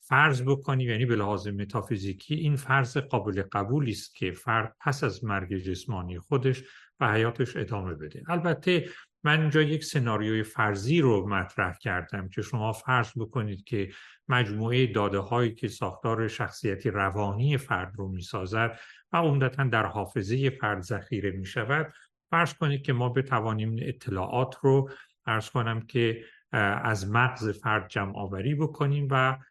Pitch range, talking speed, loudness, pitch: 105-135 Hz, 140 wpm, -28 LUFS, 120 Hz